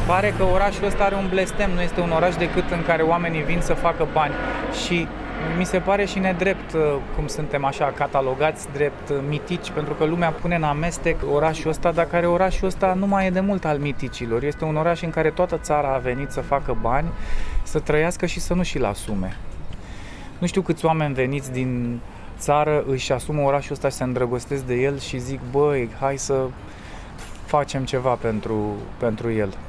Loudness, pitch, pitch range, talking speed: -23 LUFS, 150 Hz, 130-175 Hz, 190 wpm